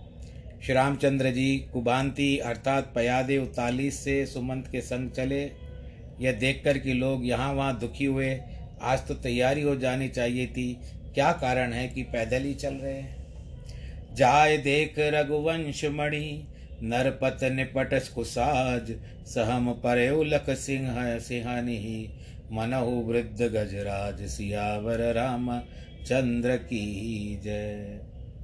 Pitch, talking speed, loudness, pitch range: 125 Hz, 115 wpm, -28 LUFS, 115-135 Hz